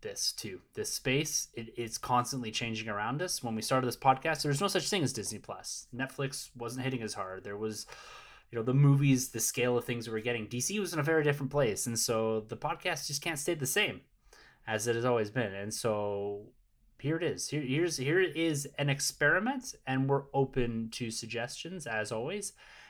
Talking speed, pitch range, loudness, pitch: 210 wpm, 115-145 Hz, -32 LUFS, 130 Hz